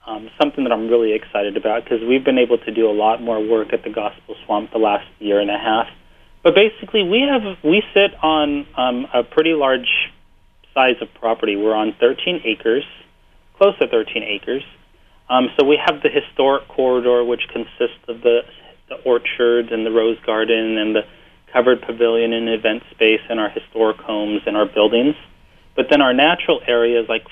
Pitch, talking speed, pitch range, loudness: 120 Hz, 190 wpm, 110-150 Hz, -17 LUFS